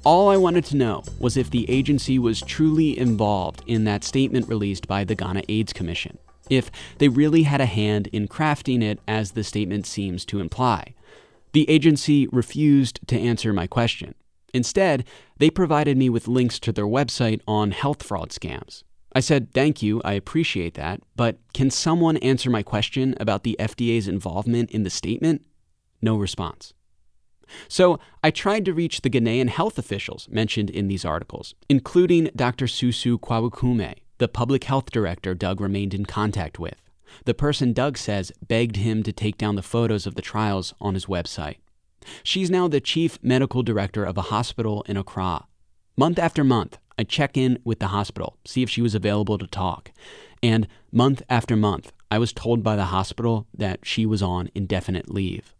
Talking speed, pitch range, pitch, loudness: 175 wpm, 100-130 Hz, 115 Hz, -23 LUFS